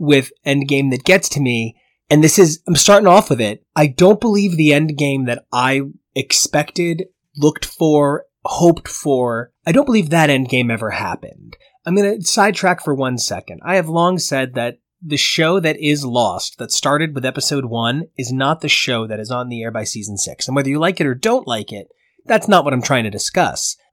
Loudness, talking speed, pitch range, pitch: -16 LUFS, 205 wpm, 130-175 Hz, 145 Hz